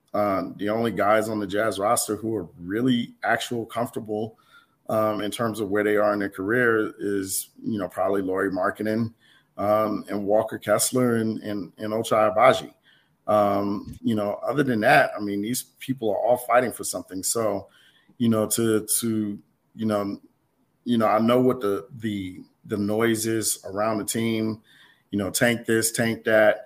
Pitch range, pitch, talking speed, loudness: 105-115 Hz, 110 Hz, 175 wpm, -24 LUFS